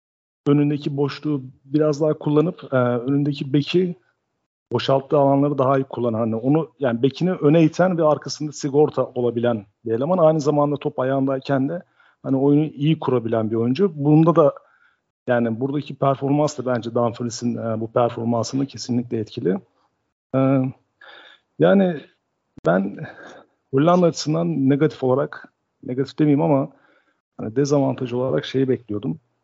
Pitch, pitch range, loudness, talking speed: 140 Hz, 125-150 Hz, -21 LUFS, 130 wpm